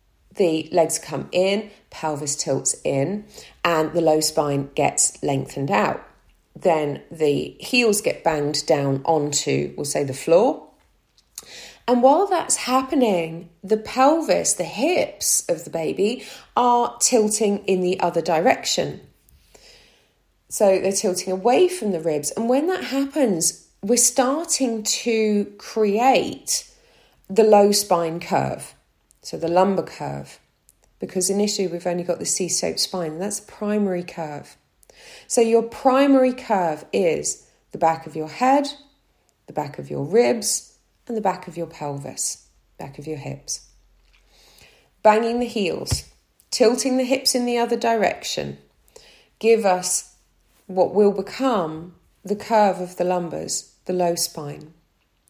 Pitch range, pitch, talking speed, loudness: 165-230 Hz, 190 Hz, 140 wpm, -21 LUFS